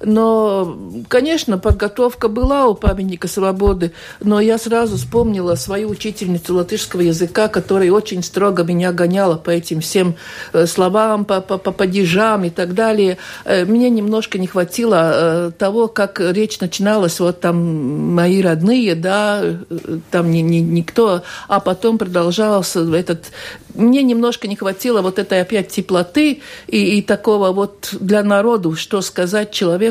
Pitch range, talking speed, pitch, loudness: 175-215 Hz, 140 wpm, 195 Hz, -16 LUFS